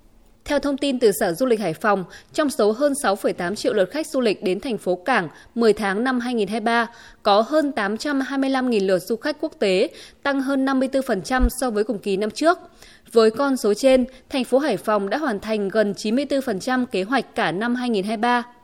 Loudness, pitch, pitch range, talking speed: -21 LUFS, 240 Hz, 210-270 Hz, 195 wpm